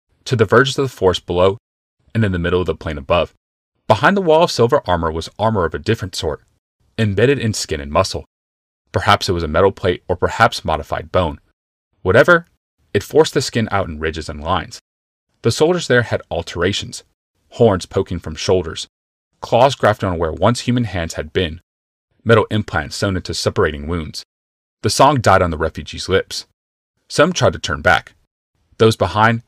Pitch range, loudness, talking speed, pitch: 80-110 Hz, -17 LUFS, 185 wpm, 90 Hz